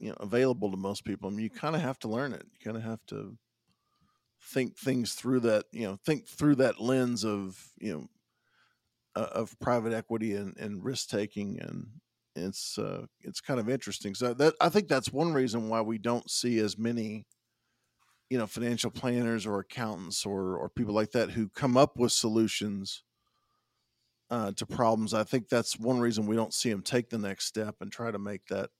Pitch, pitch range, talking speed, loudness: 115 Hz, 105-125 Hz, 205 wpm, -31 LUFS